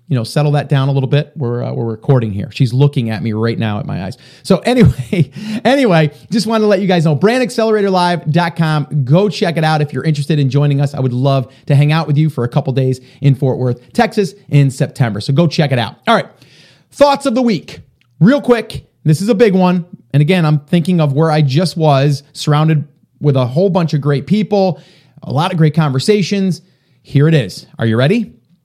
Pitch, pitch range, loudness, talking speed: 155 Hz, 135-185 Hz, -14 LUFS, 230 wpm